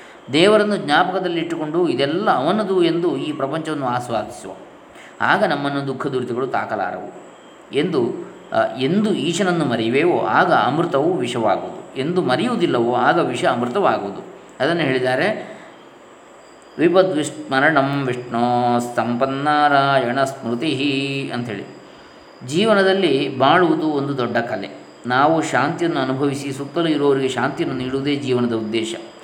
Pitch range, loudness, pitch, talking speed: 130-170 Hz, -19 LUFS, 140 Hz, 95 wpm